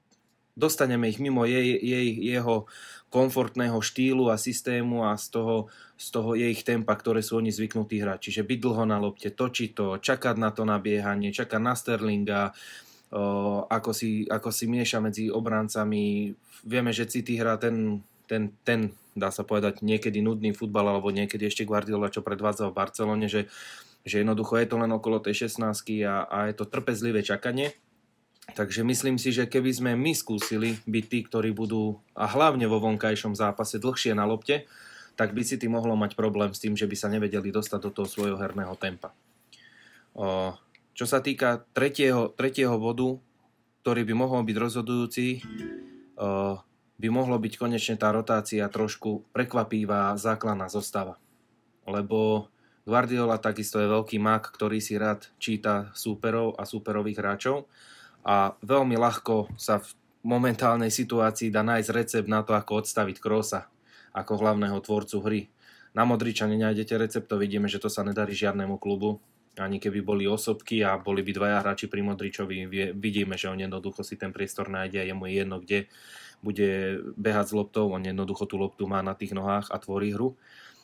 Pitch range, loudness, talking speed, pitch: 105-115 Hz, -28 LUFS, 165 wpm, 110 Hz